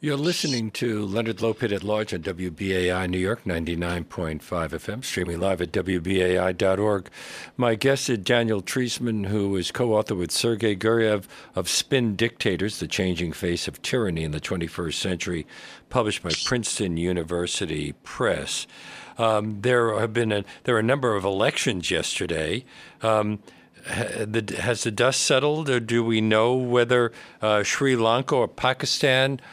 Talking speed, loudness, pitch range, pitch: 145 wpm, -24 LUFS, 90-120 Hz, 105 Hz